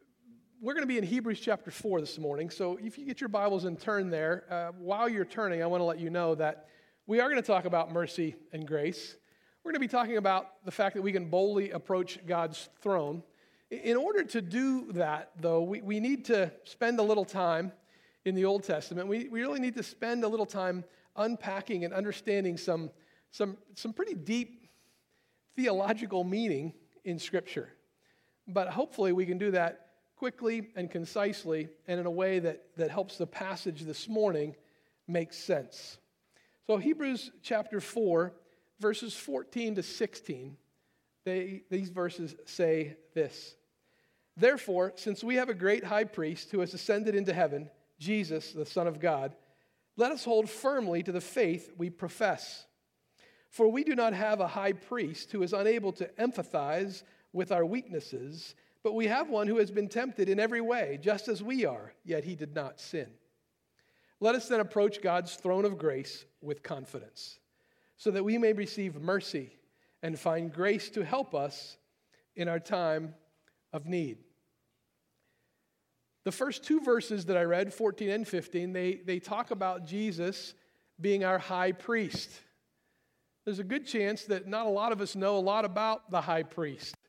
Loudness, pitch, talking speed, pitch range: -32 LUFS, 190 Hz, 175 wpm, 170-220 Hz